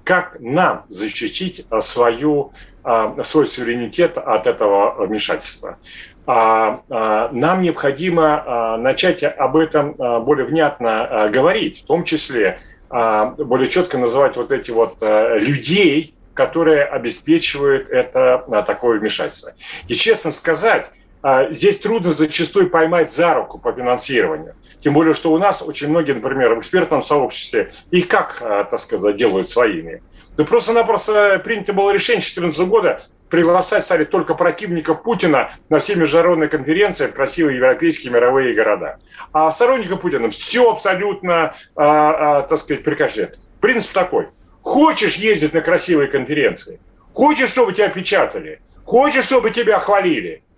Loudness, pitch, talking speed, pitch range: -16 LUFS, 170 Hz, 125 wpm, 150-230 Hz